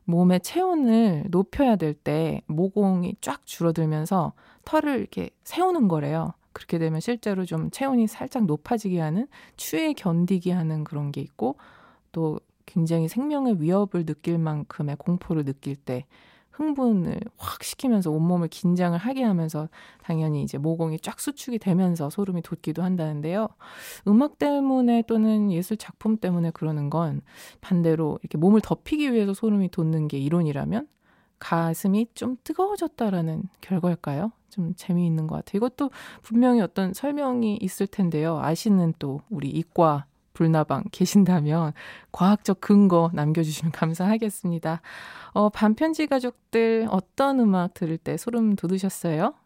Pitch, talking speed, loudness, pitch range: 185 Hz, 320 characters per minute, -25 LUFS, 165-225 Hz